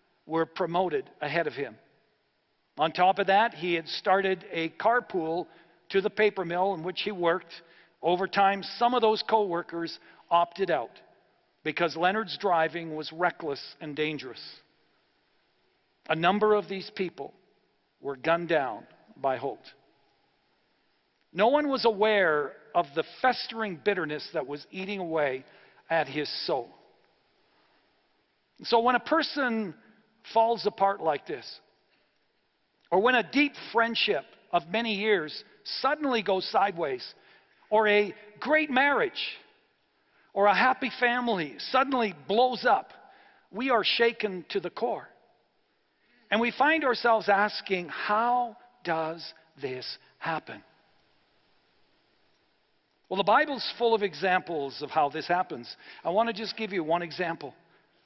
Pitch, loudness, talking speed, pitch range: 195 Hz, -27 LUFS, 130 wpm, 170-230 Hz